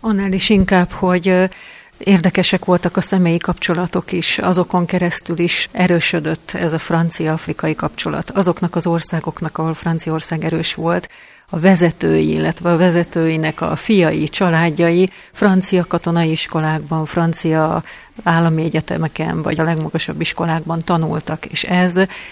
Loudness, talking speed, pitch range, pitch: -16 LUFS, 125 wpm, 160-180 Hz, 170 Hz